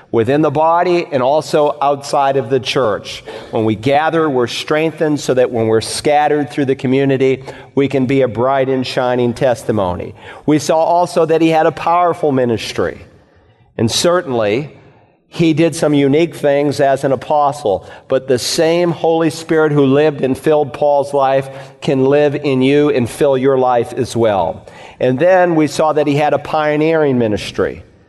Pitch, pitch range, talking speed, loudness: 145 Hz, 130-155 Hz, 170 wpm, -14 LUFS